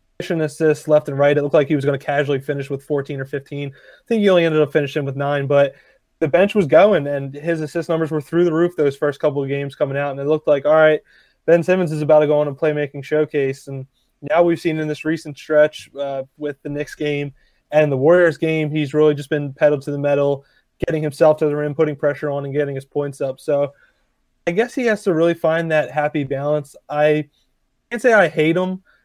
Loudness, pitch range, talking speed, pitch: -18 LUFS, 145-160 Hz, 240 wpm, 150 Hz